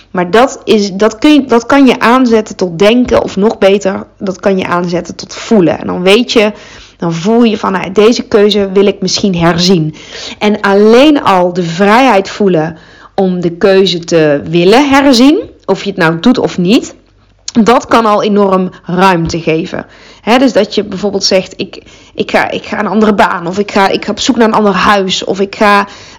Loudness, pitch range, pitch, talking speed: -9 LUFS, 185-225 Hz, 200 Hz, 200 wpm